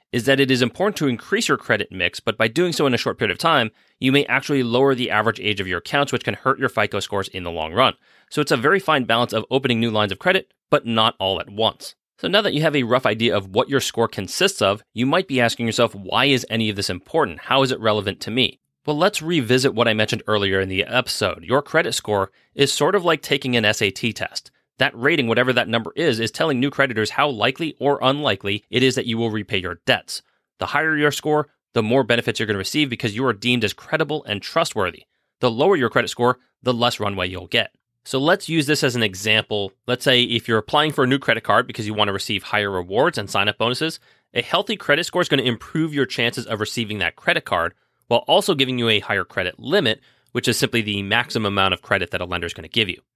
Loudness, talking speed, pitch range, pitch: -20 LUFS, 255 wpm, 105-135 Hz, 120 Hz